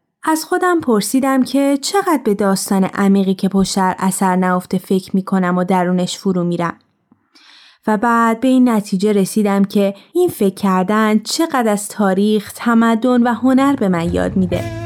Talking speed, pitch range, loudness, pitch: 160 wpm, 190-240 Hz, -15 LUFS, 205 Hz